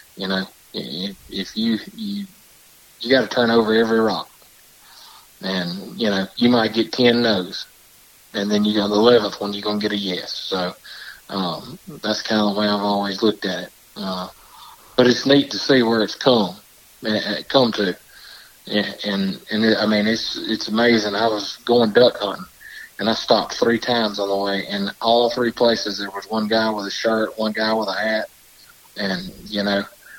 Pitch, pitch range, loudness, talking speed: 110 Hz, 100-115 Hz, -20 LUFS, 195 wpm